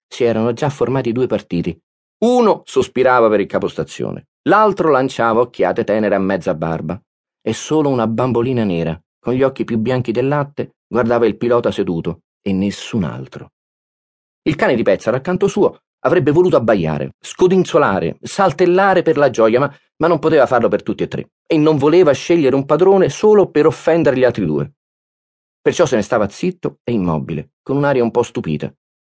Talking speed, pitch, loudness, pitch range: 175 wpm, 125 Hz, -16 LUFS, 110-160 Hz